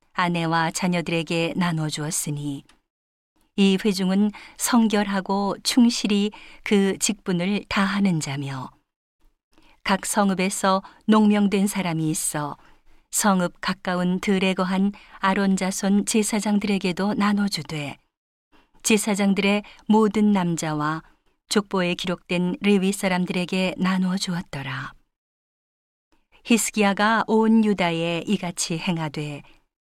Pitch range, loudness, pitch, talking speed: 175-205 Hz, -22 LUFS, 190 Hz, 230 characters per minute